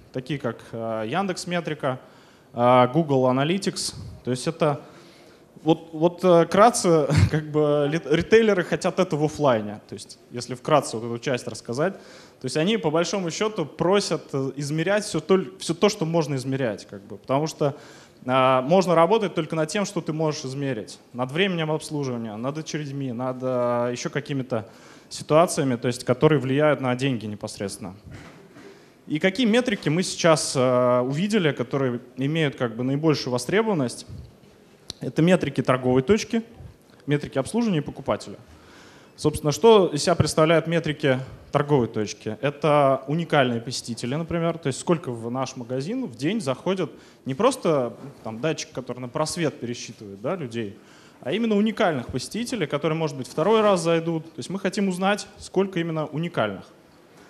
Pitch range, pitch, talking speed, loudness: 130-170 Hz, 150 Hz, 150 wpm, -23 LUFS